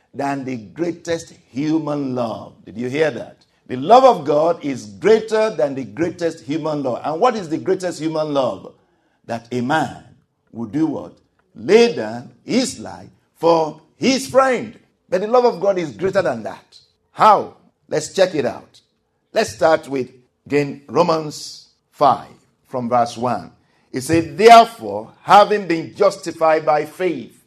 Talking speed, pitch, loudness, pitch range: 155 wpm, 160 Hz, -18 LUFS, 135-185 Hz